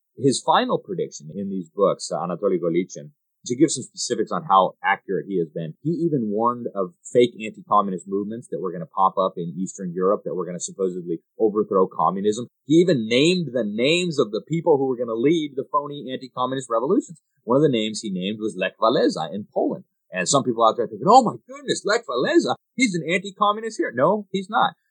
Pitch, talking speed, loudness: 125 Hz, 210 wpm, -22 LUFS